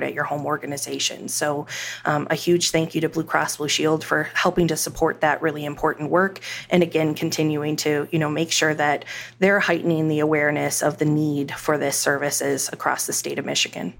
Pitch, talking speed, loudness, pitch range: 155 Hz, 200 wpm, -22 LUFS, 145-165 Hz